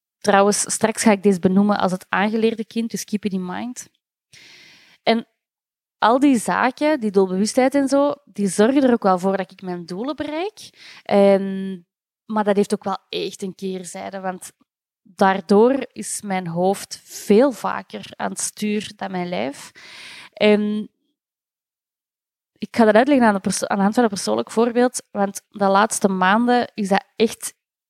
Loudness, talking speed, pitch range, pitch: -20 LUFS, 170 wpm, 195-235 Hz, 210 Hz